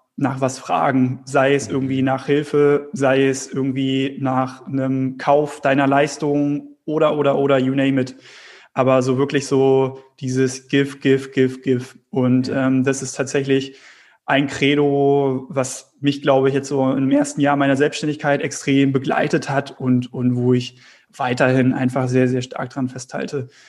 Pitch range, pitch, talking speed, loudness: 130-140 Hz, 135 Hz, 160 wpm, -19 LUFS